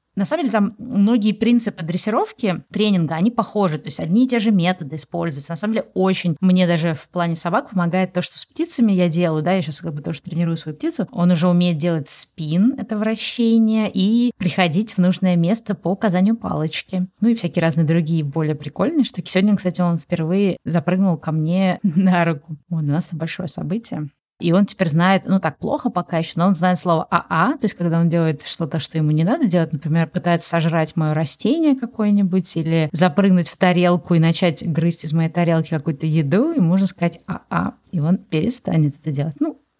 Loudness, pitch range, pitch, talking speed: -19 LUFS, 165-200 Hz, 180 Hz, 205 wpm